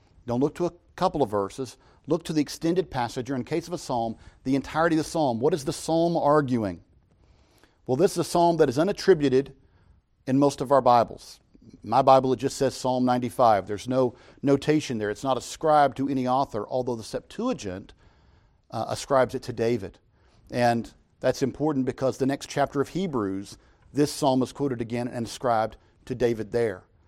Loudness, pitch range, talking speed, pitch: -25 LUFS, 115-145 Hz, 190 wpm, 130 Hz